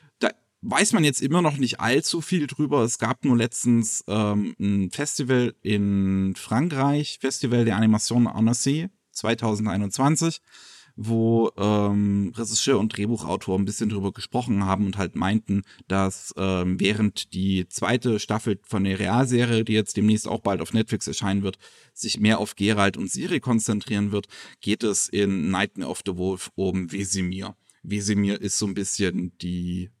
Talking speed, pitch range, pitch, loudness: 155 wpm, 100-120 Hz, 105 Hz, -24 LUFS